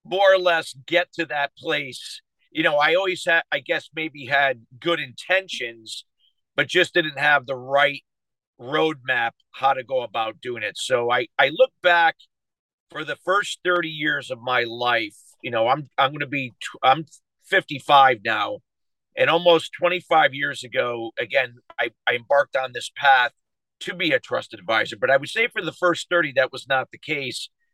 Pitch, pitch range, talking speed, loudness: 150 Hz, 130-175 Hz, 180 wpm, -22 LUFS